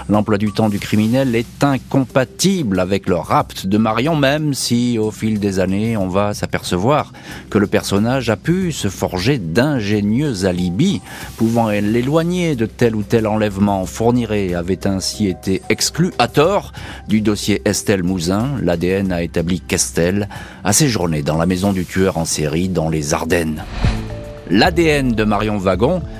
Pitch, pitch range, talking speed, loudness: 105 Hz, 95-120 Hz, 155 wpm, -17 LUFS